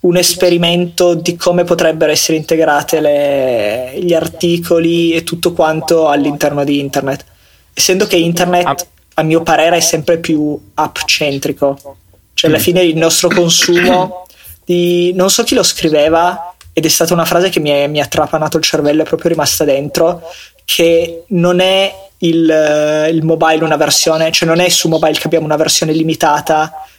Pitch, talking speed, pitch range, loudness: 165 Hz, 160 wpm, 150-175 Hz, -11 LUFS